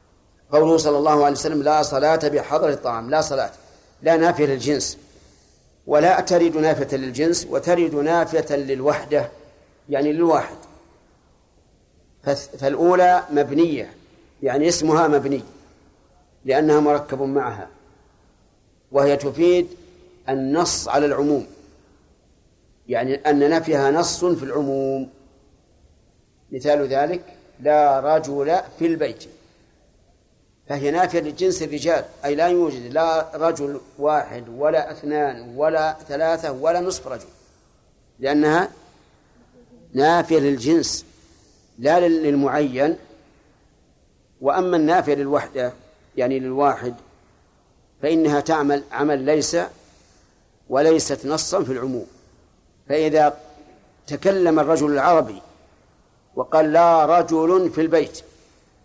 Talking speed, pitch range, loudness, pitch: 95 wpm, 135-160 Hz, -20 LUFS, 145 Hz